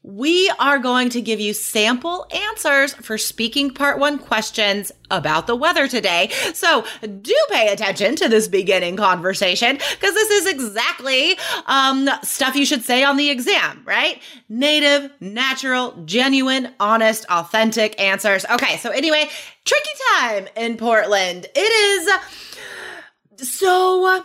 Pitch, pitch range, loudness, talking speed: 265 Hz, 220-305 Hz, -17 LUFS, 135 wpm